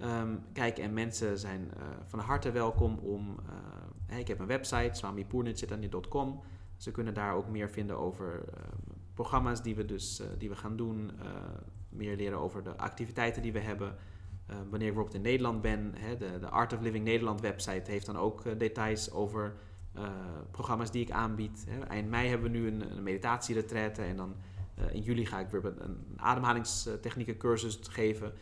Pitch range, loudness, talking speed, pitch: 95-115 Hz, -36 LUFS, 190 wpm, 105 Hz